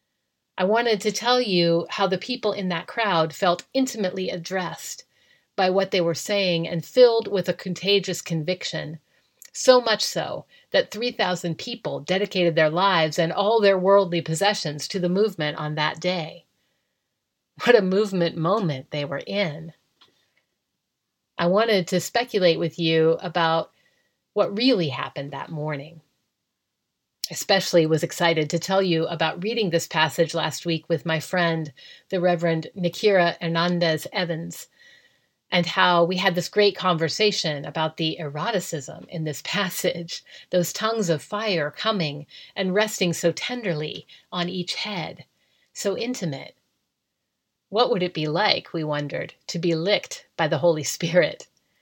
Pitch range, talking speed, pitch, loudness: 165-200 Hz, 145 wpm, 175 Hz, -23 LUFS